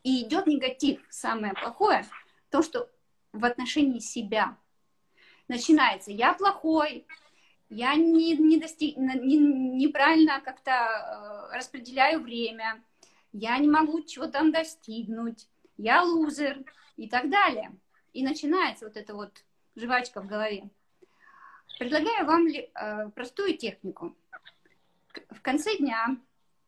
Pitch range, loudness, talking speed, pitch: 240-320 Hz, -26 LUFS, 110 wpm, 280 Hz